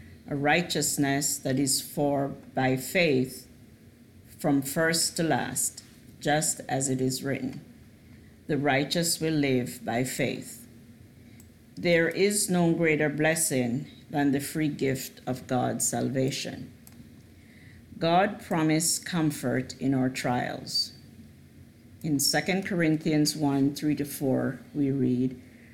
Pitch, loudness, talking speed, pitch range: 140 Hz, -27 LUFS, 115 wpm, 125-155 Hz